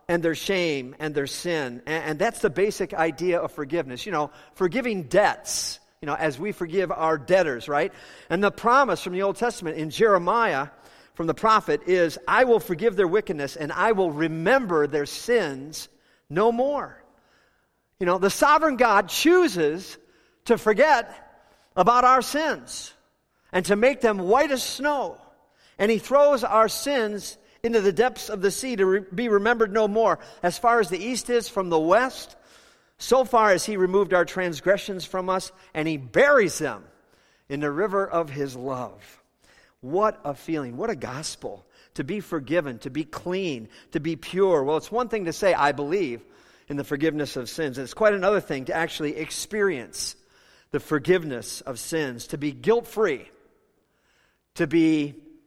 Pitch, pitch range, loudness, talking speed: 185 Hz, 155-220 Hz, -23 LUFS, 170 wpm